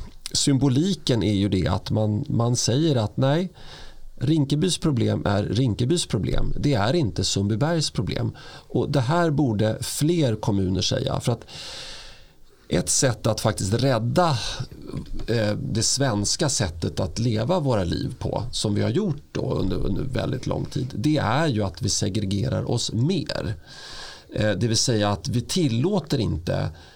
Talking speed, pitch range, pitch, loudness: 150 wpm, 105-140 Hz, 120 Hz, -23 LUFS